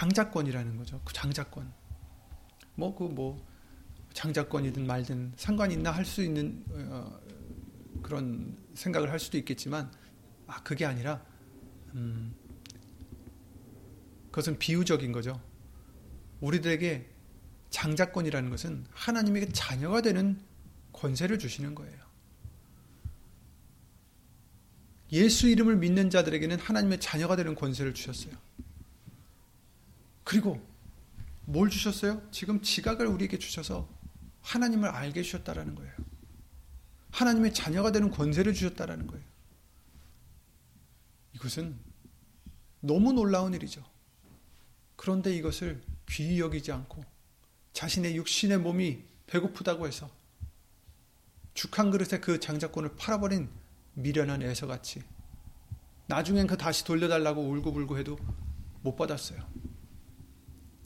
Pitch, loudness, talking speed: 145 Hz, -31 LUFS, 250 characters per minute